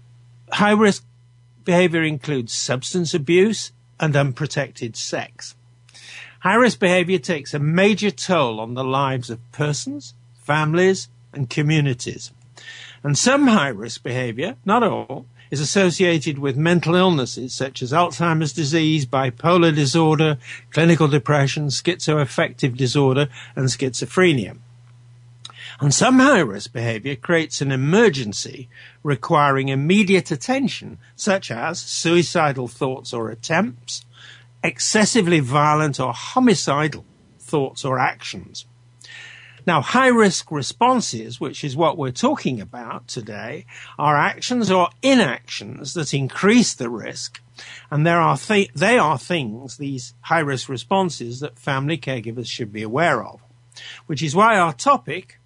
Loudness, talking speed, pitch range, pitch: -19 LUFS, 125 wpm, 120-170 Hz, 145 Hz